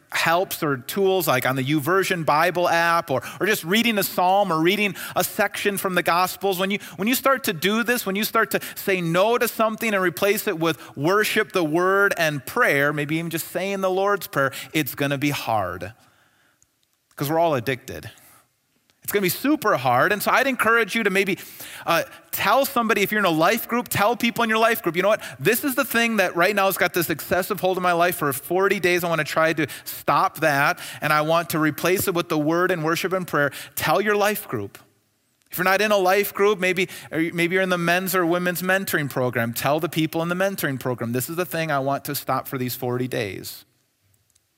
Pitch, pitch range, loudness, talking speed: 180 Hz, 155-200 Hz, -21 LUFS, 230 wpm